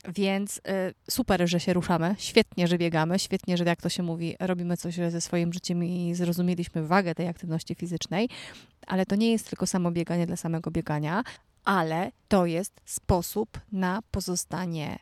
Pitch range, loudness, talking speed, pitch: 170-190 Hz, -28 LUFS, 170 wpm, 175 Hz